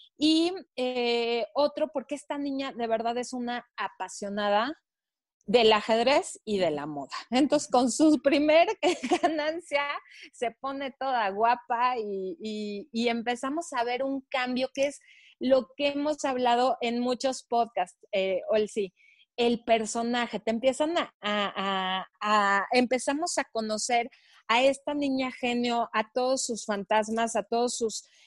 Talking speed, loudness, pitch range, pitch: 145 wpm, -28 LUFS, 220-275 Hz, 245 Hz